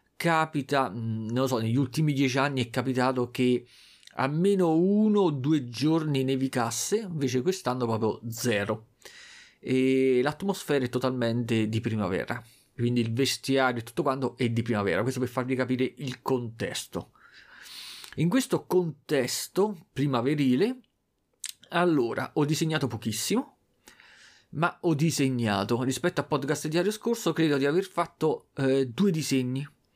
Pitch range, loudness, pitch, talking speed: 120-155 Hz, -27 LUFS, 135 Hz, 130 wpm